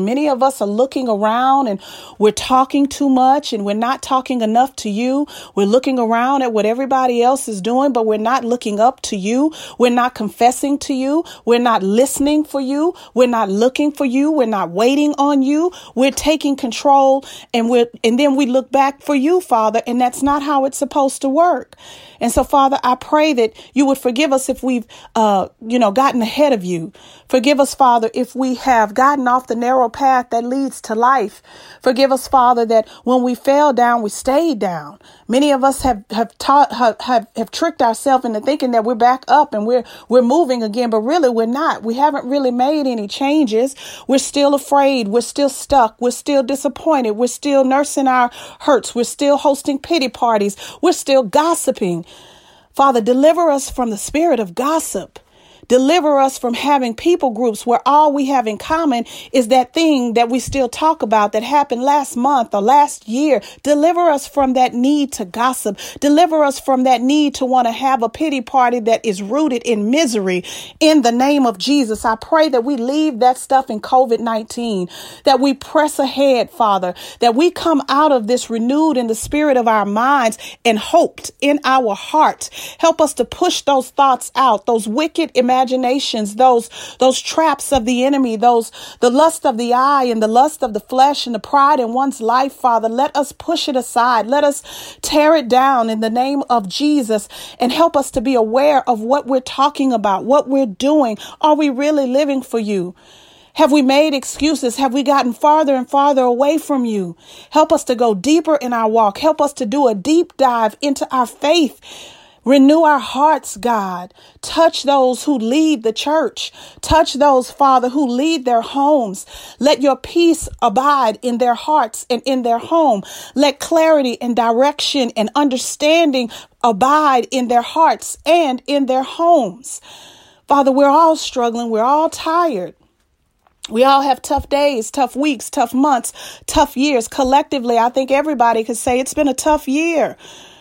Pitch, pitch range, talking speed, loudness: 265 Hz, 240-290 Hz, 190 wpm, -15 LUFS